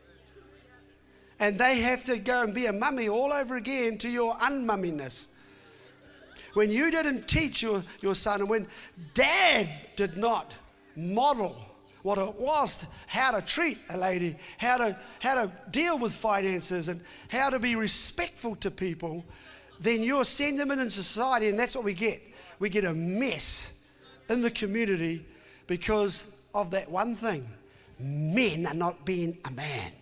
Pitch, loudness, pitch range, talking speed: 210 Hz, -28 LUFS, 180-245 Hz, 155 wpm